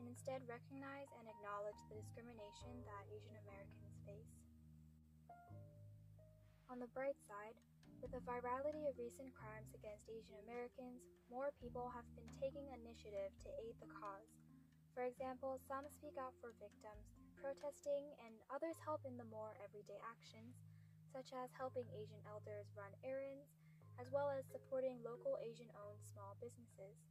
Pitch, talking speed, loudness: 155 Hz, 145 wpm, -52 LUFS